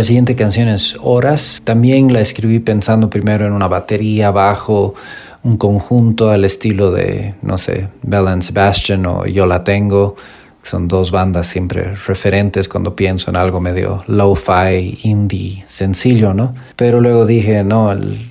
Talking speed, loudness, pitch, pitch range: 155 wpm, -13 LUFS, 100 Hz, 95-110 Hz